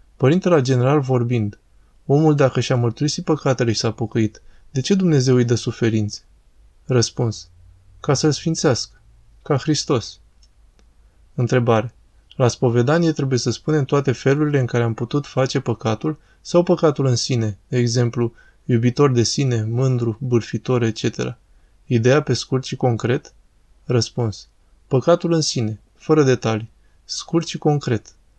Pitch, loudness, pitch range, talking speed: 125 Hz, -19 LUFS, 110-140 Hz, 135 wpm